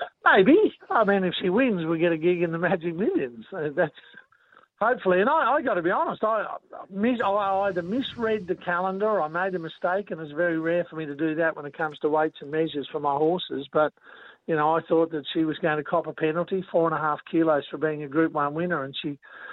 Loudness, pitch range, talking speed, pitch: -25 LUFS, 155-190 Hz, 250 wpm, 170 Hz